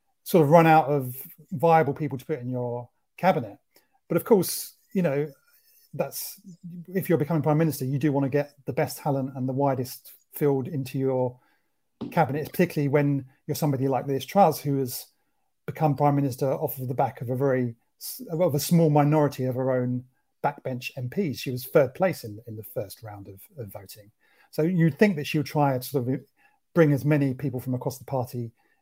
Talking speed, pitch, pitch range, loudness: 200 wpm, 140 Hz, 130-155 Hz, -25 LUFS